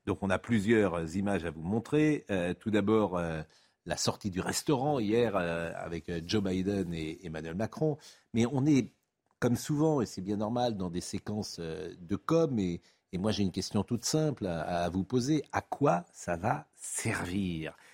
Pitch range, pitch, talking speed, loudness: 90-120 Hz, 100 Hz, 190 wpm, -32 LUFS